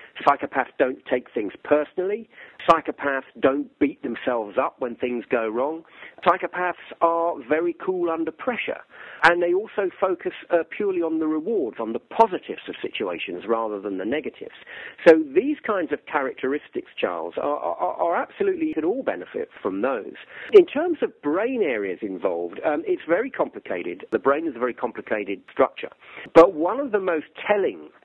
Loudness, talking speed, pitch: -23 LUFS, 165 wpm, 180 Hz